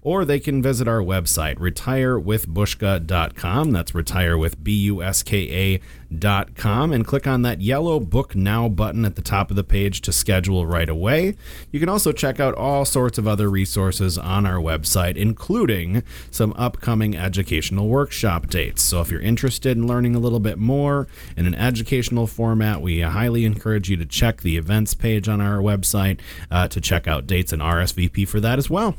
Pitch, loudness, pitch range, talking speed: 105 Hz, -21 LUFS, 90-120 Hz, 170 wpm